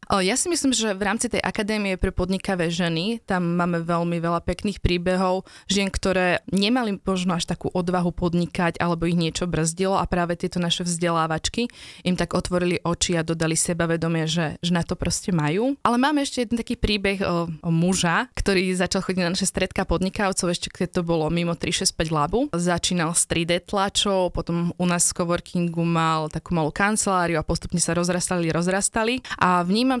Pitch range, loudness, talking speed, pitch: 170-195 Hz, -23 LUFS, 180 wpm, 180 Hz